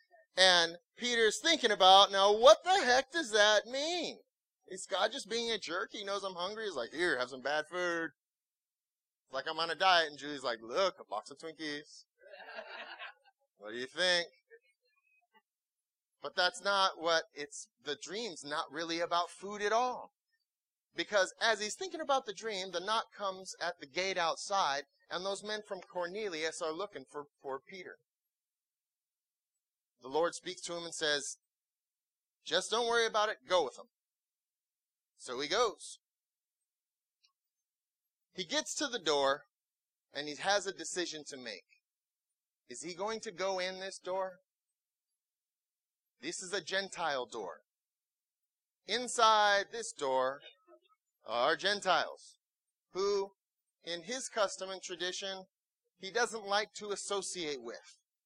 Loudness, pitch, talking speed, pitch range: -33 LUFS, 195 Hz, 145 wpm, 170-225 Hz